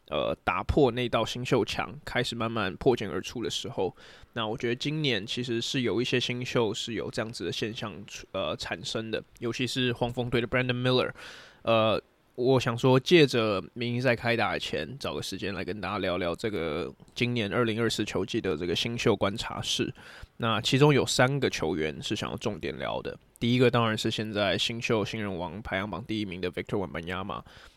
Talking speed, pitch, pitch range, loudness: 325 characters per minute, 115 Hz, 105-125 Hz, -28 LUFS